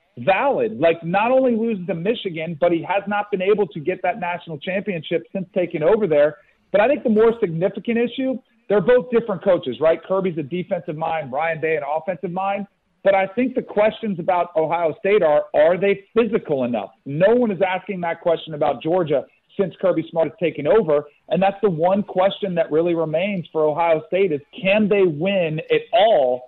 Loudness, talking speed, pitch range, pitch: -20 LUFS, 195 wpm, 165-210 Hz, 190 Hz